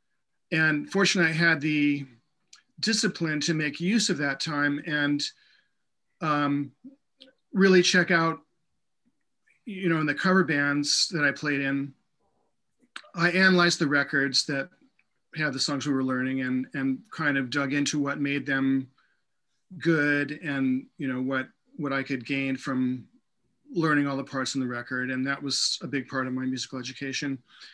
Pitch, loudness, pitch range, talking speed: 145 Hz, -26 LUFS, 135-165 Hz, 160 wpm